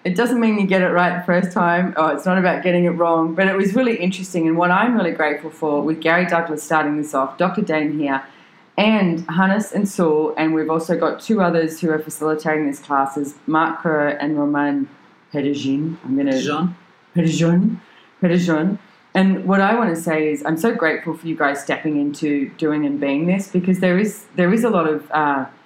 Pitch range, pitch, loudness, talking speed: 150-185 Hz, 165 Hz, -19 LUFS, 200 wpm